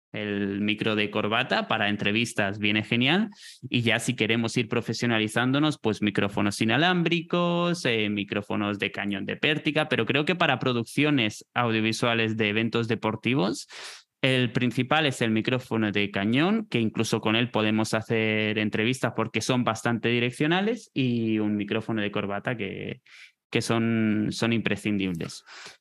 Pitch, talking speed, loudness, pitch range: 115 Hz, 140 wpm, -25 LUFS, 105-130 Hz